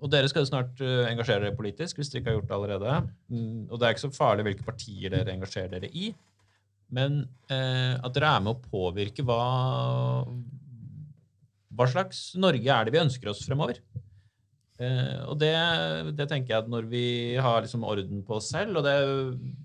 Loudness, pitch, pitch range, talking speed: -28 LUFS, 125 Hz, 105-140 Hz, 185 wpm